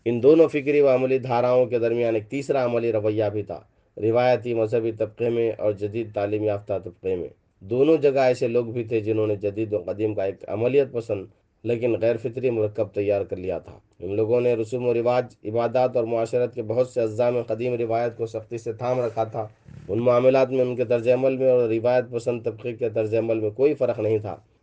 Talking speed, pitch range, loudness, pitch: 215 wpm, 110-125 Hz, -23 LUFS, 120 Hz